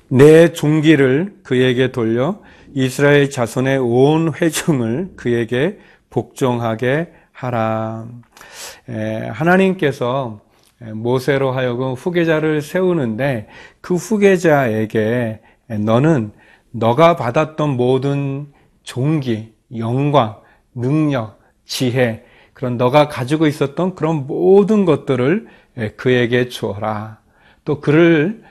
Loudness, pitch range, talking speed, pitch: -16 LUFS, 120-155 Hz, 205 characters per minute, 130 Hz